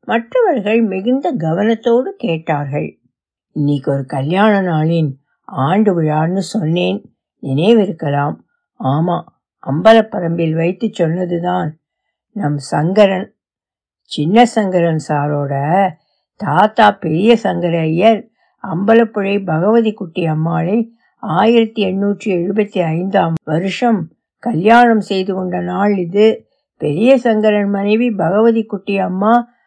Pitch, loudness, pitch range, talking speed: 190 Hz, -15 LUFS, 160-220 Hz, 90 wpm